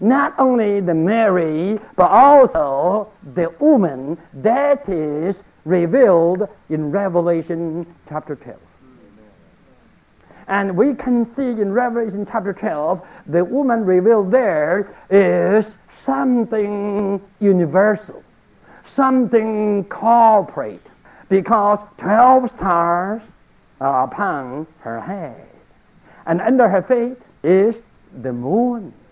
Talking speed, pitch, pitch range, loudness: 95 wpm, 205 Hz, 175-235 Hz, -17 LUFS